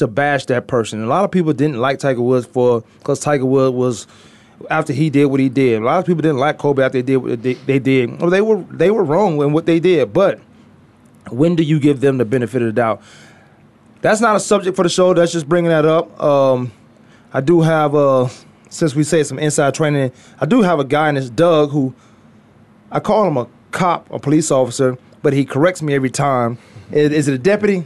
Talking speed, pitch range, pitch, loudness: 235 wpm, 130-160 Hz, 145 Hz, -16 LUFS